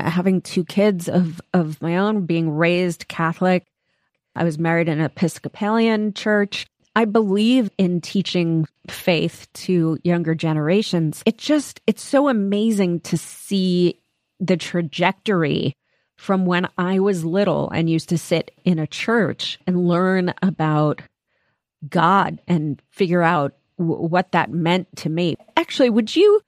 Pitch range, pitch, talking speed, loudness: 165-200 Hz, 180 Hz, 140 wpm, -20 LUFS